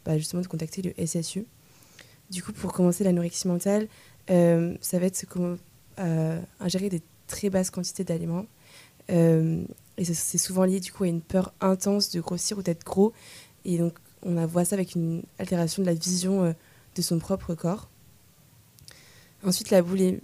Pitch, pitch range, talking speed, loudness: 180 Hz, 170-190 Hz, 180 wpm, -27 LUFS